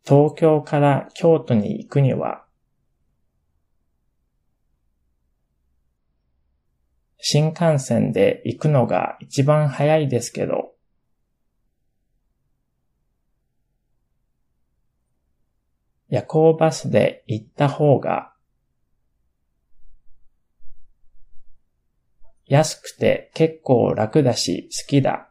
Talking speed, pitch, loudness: 115 characters per minute, 105 Hz, -19 LUFS